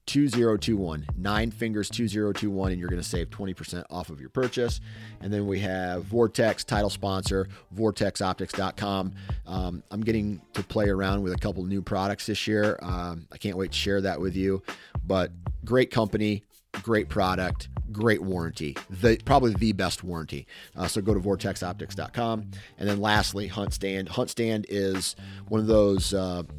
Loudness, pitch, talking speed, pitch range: -28 LUFS, 100 Hz, 165 wpm, 95-110 Hz